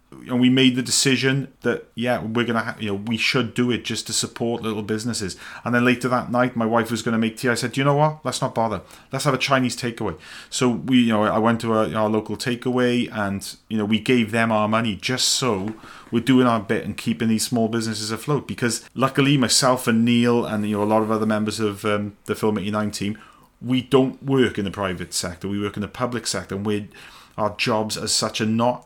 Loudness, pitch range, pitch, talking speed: -21 LUFS, 105-125 Hz, 115 Hz, 250 wpm